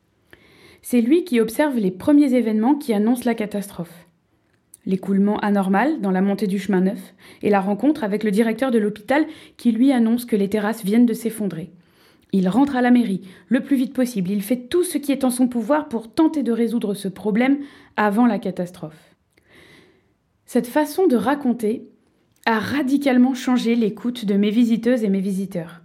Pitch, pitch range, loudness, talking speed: 225 Hz, 200-255 Hz, -20 LUFS, 180 wpm